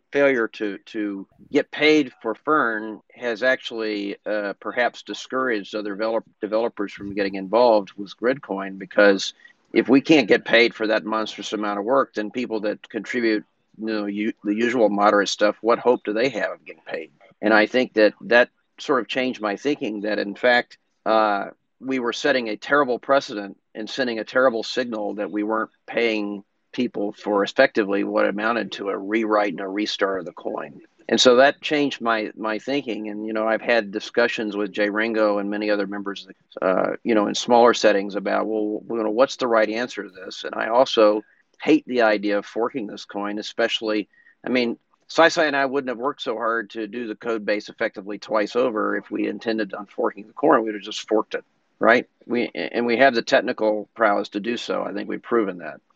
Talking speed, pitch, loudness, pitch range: 200 wpm, 110 Hz, -22 LUFS, 105-120 Hz